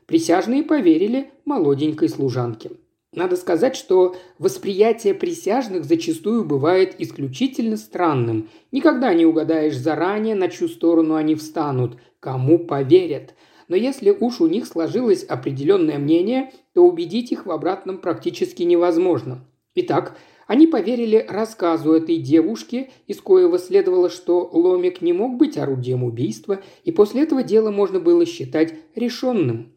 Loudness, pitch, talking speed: -19 LUFS, 220 Hz, 125 wpm